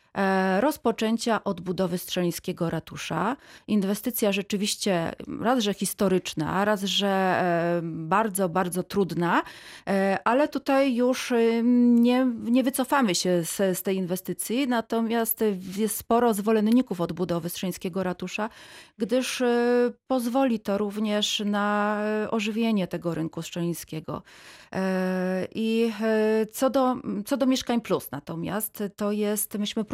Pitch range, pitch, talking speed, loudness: 185-235 Hz, 210 Hz, 105 wpm, -25 LUFS